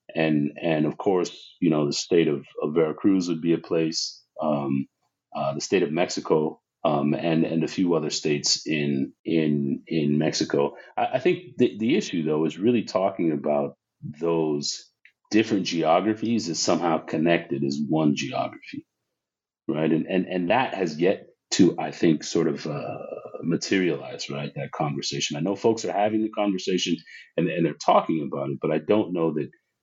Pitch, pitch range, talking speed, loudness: 80 Hz, 75-95 Hz, 175 wpm, -25 LUFS